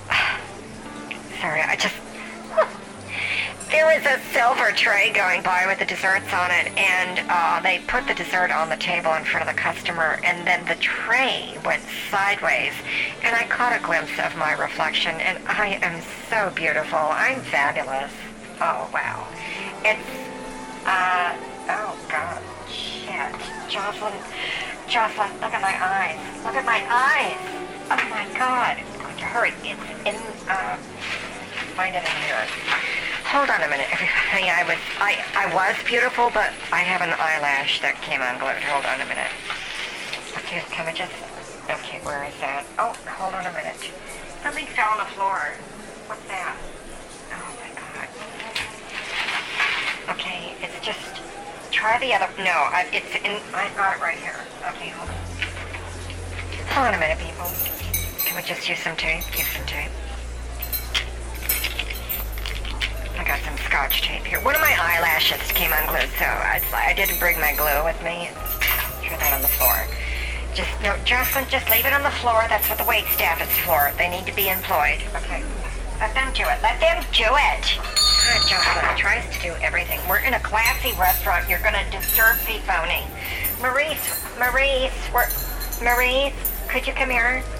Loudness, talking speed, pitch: -22 LUFS, 165 wpm, 175 Hz